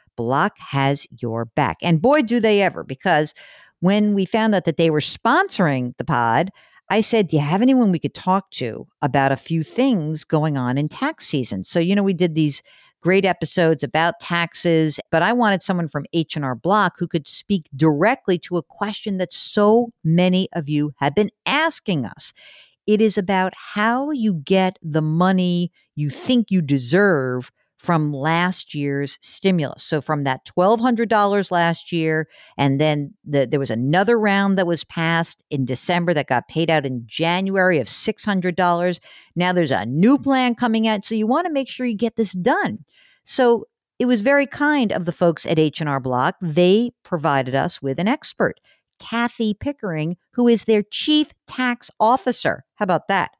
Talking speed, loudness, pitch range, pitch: 180 wpm, -20 LUFS, 150-210 Hz, 175 Hz